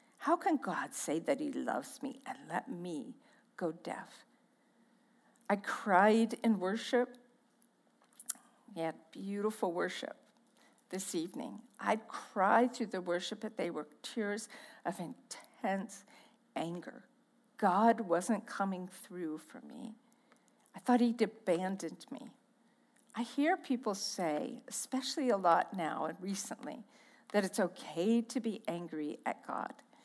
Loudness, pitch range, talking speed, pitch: -36 LUFS, 195-255 Hz, 130 wpm, 230 Hz